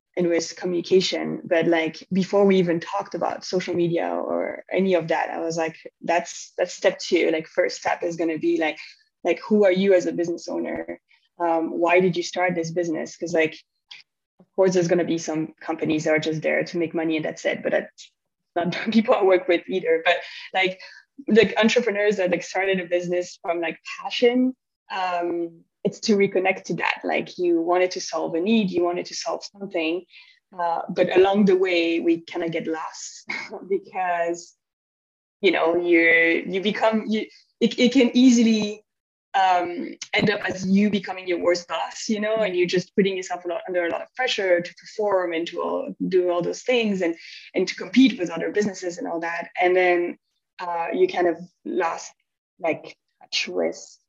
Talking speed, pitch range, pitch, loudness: 200 wpm, 170-200 Hz, 180 Hz, -23 LUFS